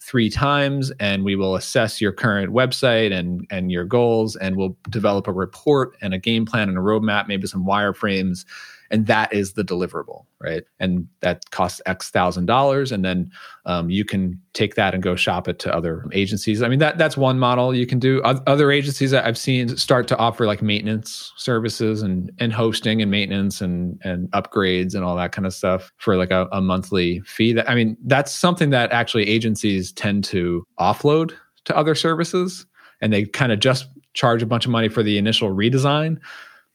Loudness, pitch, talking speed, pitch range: -20 LUFS, 110 Hz, 200 wpm, 95-125 Hz